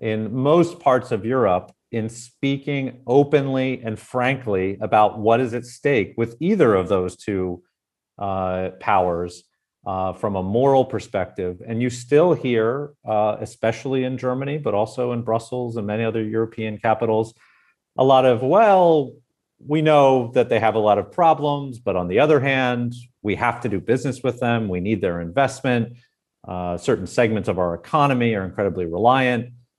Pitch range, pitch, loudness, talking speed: 105-130 Hz, 120 Hz, -21 LUFS, 165 wpm